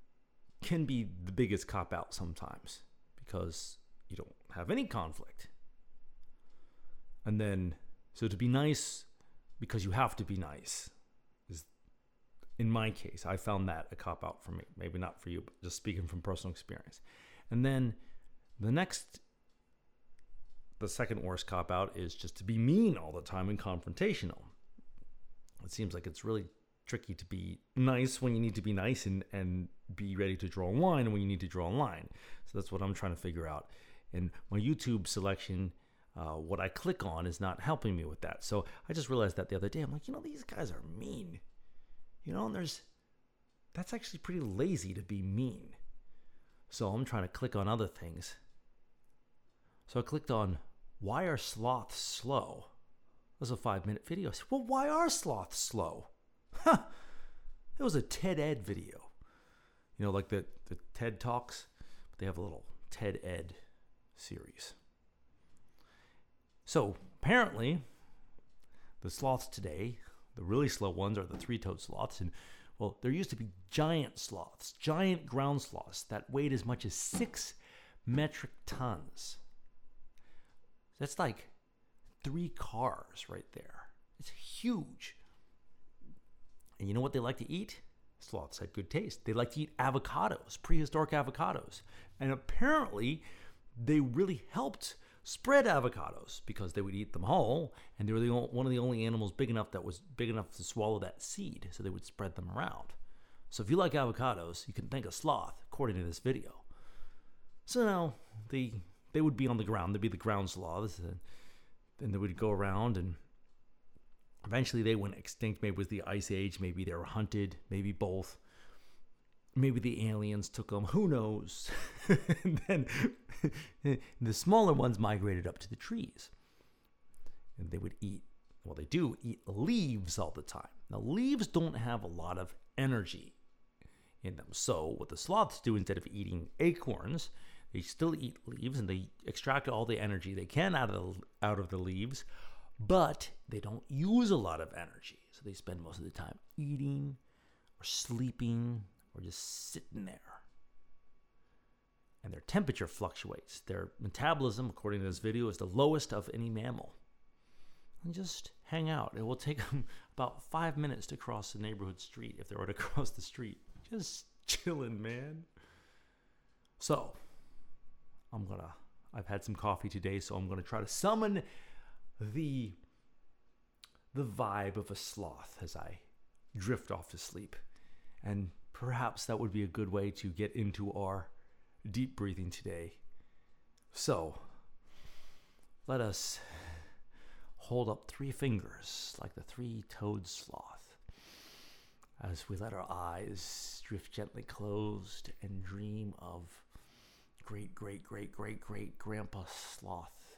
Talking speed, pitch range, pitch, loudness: 165 wpm, 95-130 Hz, 105 Hz, -38 LUFS